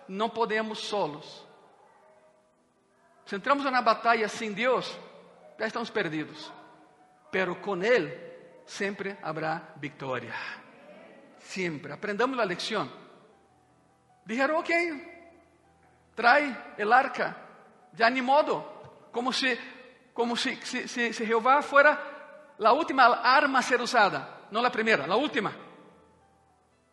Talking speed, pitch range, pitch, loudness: 115 wpm, 200-280 Hz, 235 Hz, -27 LUFS